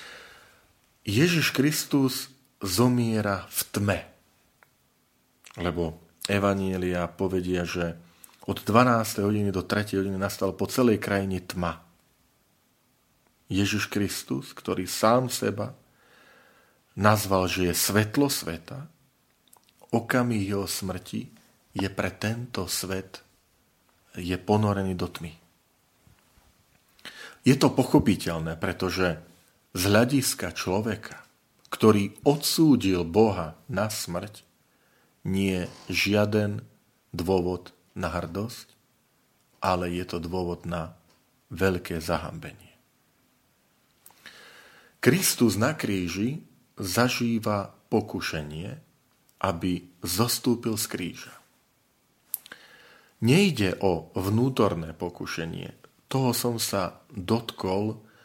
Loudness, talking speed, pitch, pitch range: -26 LUFS, 85 wpm, 100 Hz, 90-120 Hz